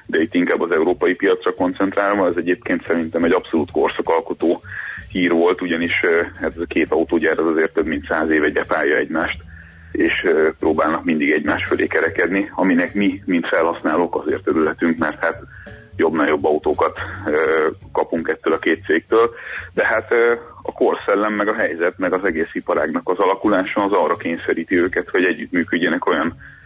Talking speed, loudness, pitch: 160 wpm, -19 LUFS, 100 Hz